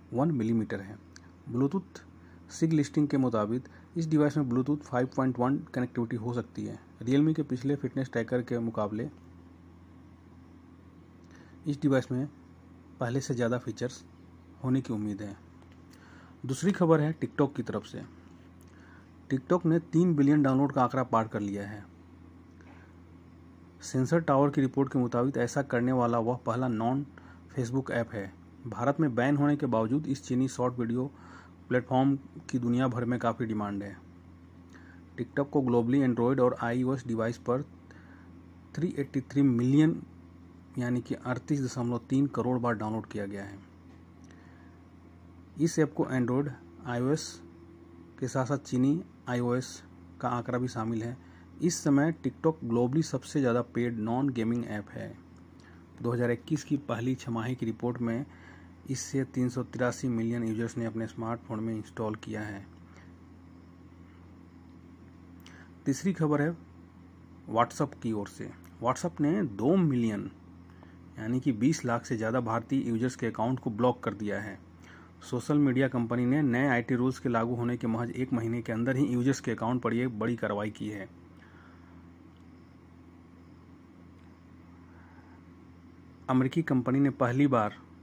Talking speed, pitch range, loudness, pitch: 145 wpm, 90-130 Hz, -30 LUFS, 115 Hz